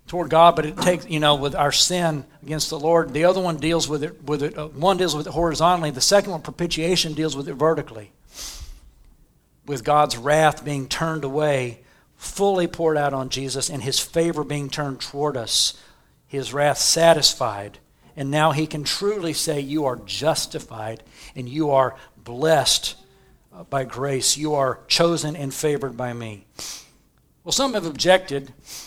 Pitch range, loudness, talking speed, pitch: 135-165 Hz, -21 LUFS, 170 wpm, 150 Hz